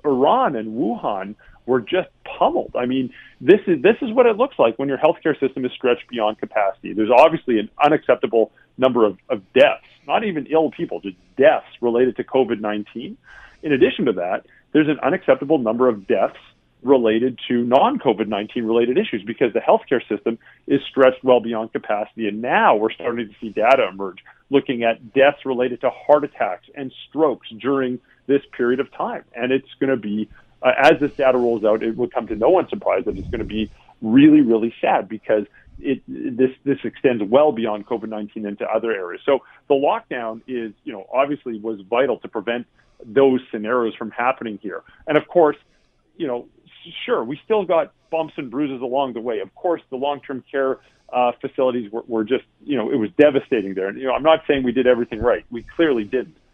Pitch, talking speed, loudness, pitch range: 125 Hz, 200 wpm, -20 LUFS, 115-140 Hz